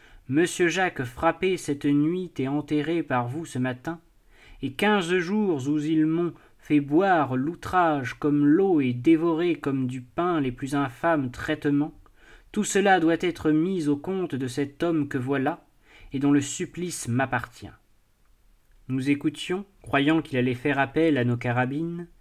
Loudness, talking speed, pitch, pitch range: -25 LUFS, 155 wpm, 150 Hz, 135-170 Hz